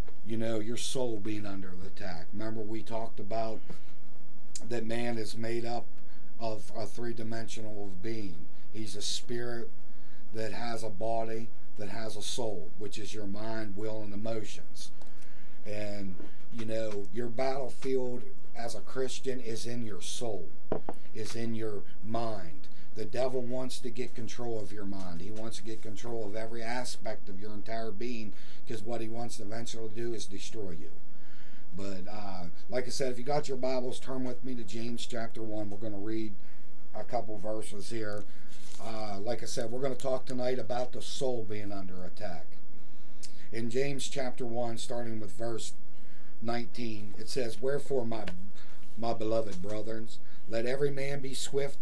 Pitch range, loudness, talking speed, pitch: 105-120 Hz, -38 LUFS, 170 wpm, 115 Hz